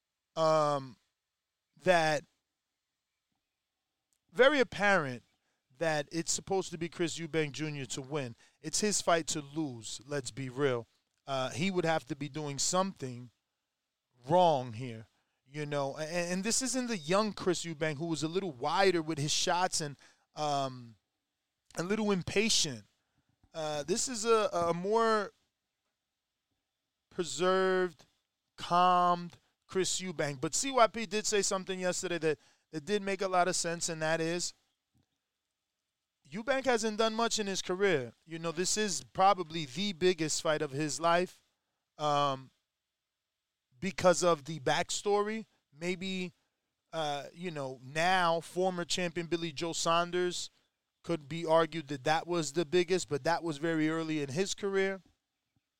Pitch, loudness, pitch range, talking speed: 170 Hz, -32 LUFS, 150-185 Hz, 140 wpm